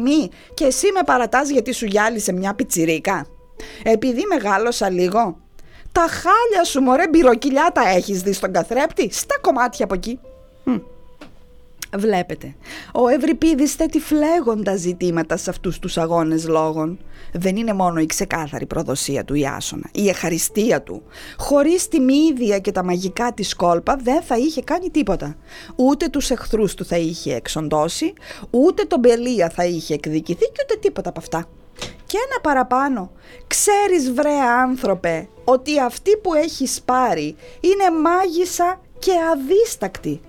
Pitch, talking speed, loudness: 240 Hz, 140 wpm, -19 LUFS